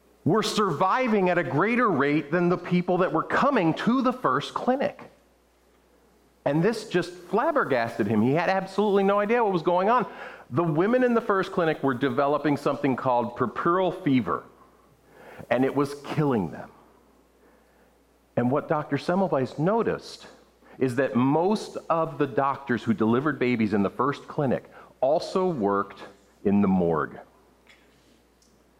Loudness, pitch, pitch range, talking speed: -25 LUFS, 165 Hz, 135-190 Hz, 145 wpm